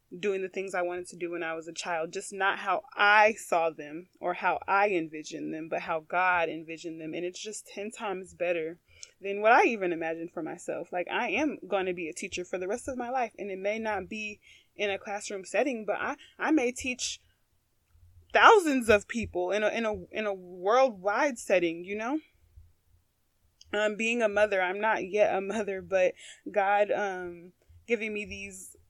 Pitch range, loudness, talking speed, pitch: 165-210 Hz, -29 LUFS, 200 wpm, 190 Hz